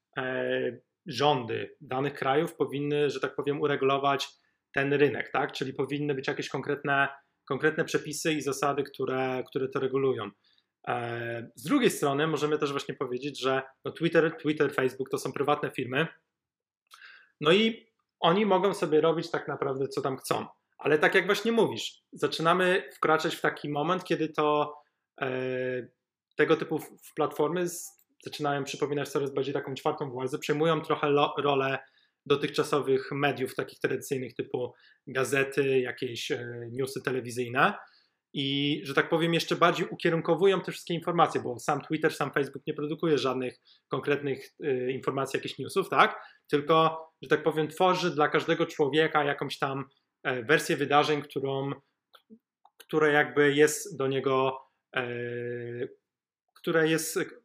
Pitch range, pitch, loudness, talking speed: 135-160 Hz, 145 Hz, -28 LUFS, 145 wpm